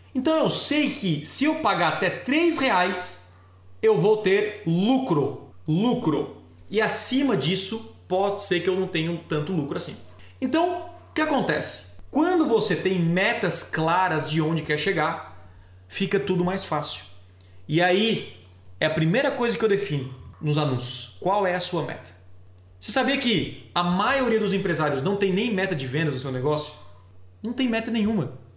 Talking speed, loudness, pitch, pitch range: 170 wpm, -24 LUFS, 180 Hz, 150-215 Hz